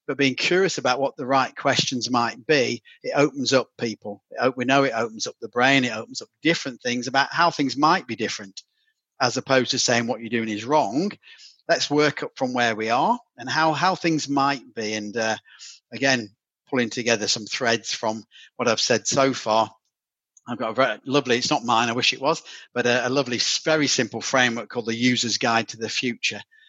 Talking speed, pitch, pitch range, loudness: 210 wpm, 125 Hz, 115-140 Hz, -22 LUFS